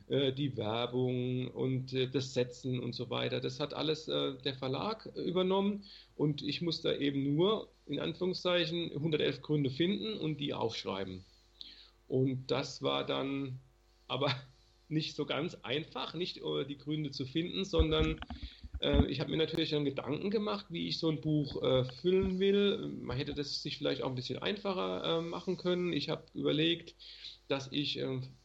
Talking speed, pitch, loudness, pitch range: 165 wpm, 145 Hz, -35 LUFS, 125-165 Hz